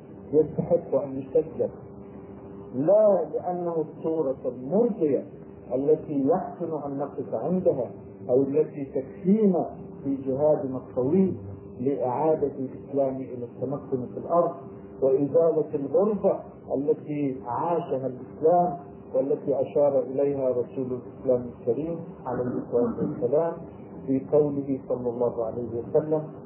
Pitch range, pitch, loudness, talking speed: 125-165 Hz, 140 Hz, -26 LUFS, 100 wpm